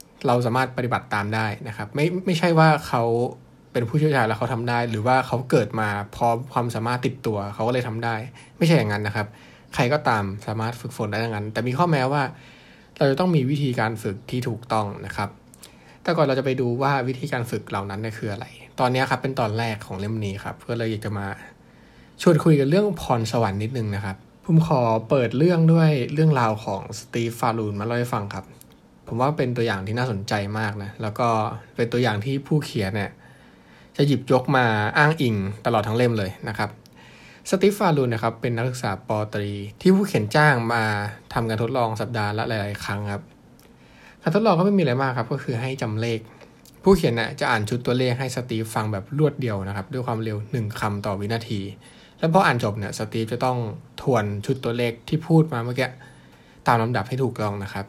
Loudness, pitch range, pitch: -23 LUFS, 110-135 Hz, 120 Hz